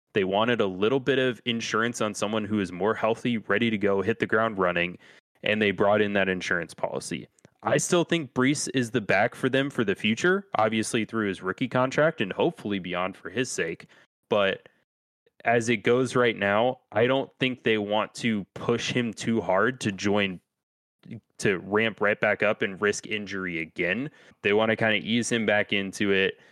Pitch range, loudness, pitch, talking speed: 100-125 Hz, -26 LUFS, 110 Hz, 195 wpm